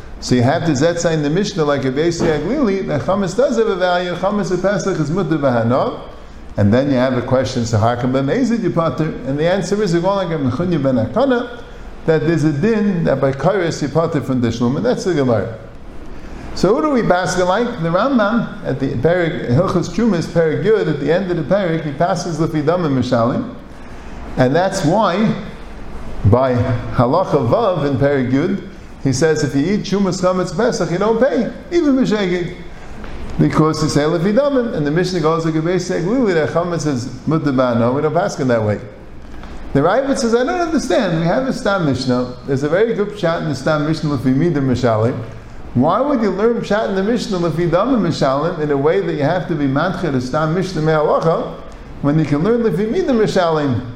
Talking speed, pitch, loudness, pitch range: 185 wpm, 165 Hz, -16 LUFS, 140-195 Hz